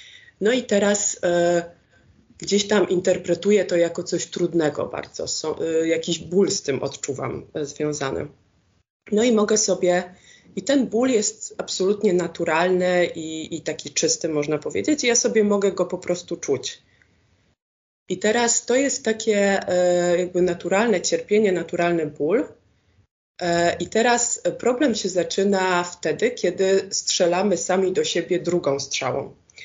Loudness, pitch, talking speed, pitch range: -22 LUFS, 180 Hz, 140 wpm, 170-210 Hz